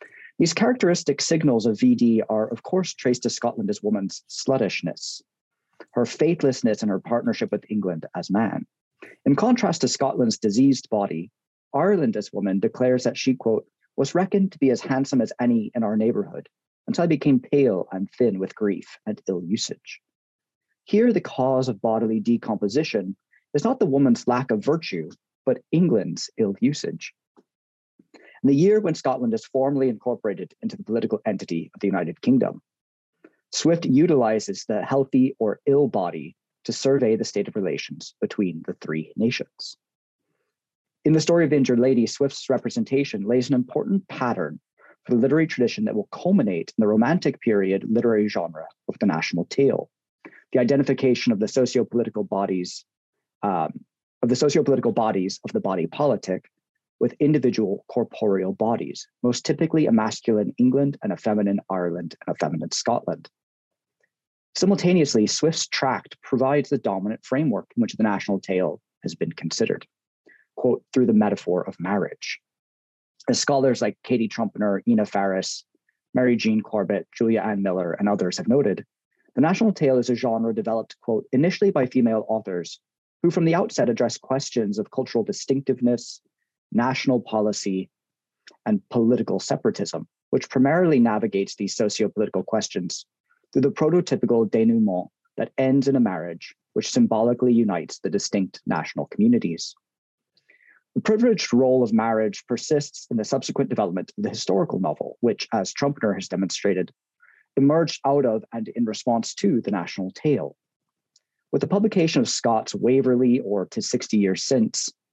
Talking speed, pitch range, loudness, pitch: 155 wpm, 110-150 Hz, -23 LUFS, 125 Hz